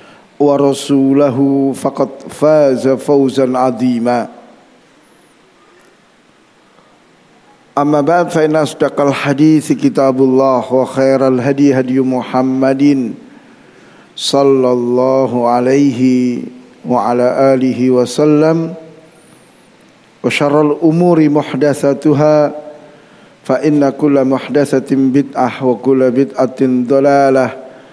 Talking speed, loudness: 80 wpm, -12 LUFS